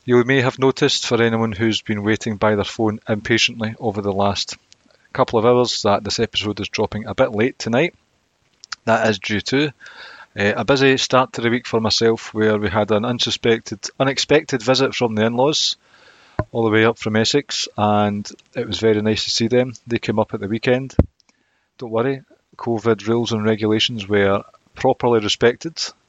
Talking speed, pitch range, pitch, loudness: 185 wpm, 105-125 Hz, 115 Hz, -19 LUFS